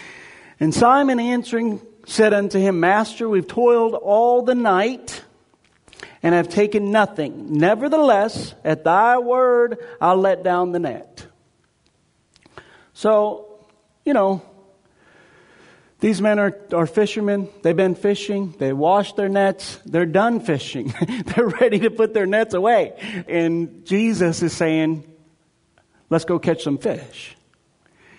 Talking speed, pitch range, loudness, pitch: 125 wpm, 170-225 Hz, -19 LUFS, 200 Hz